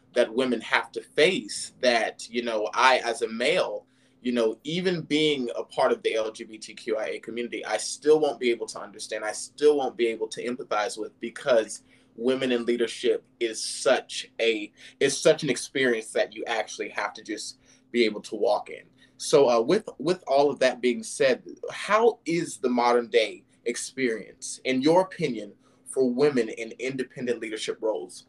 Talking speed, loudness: 175 wpm, -26 LUFS